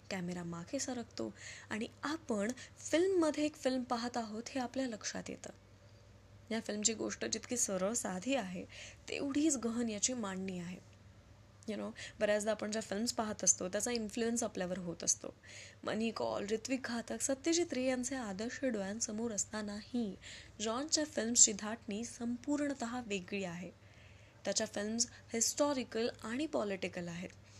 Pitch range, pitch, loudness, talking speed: 185-245 Hz, 220 Hz, -37 LUFS, 135 wpm